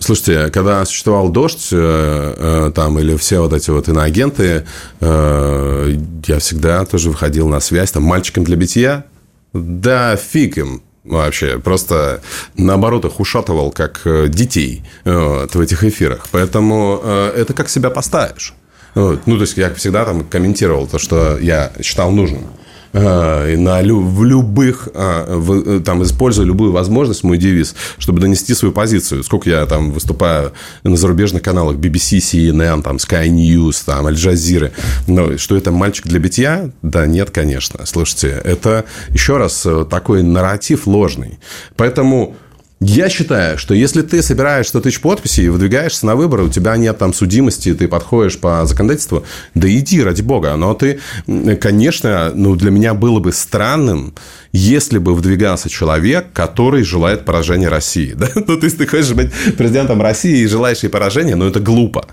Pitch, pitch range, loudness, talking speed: 90 Hz, 80-110 Hz, -13 LUFS, 155 wpm